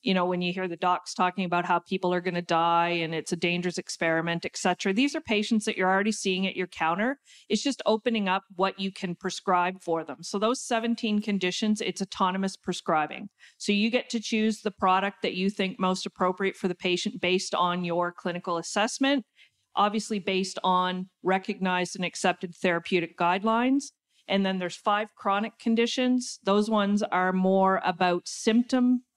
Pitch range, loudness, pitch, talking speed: 180-215 Hz, -27 LUFS, 190 Hz, 185 wpm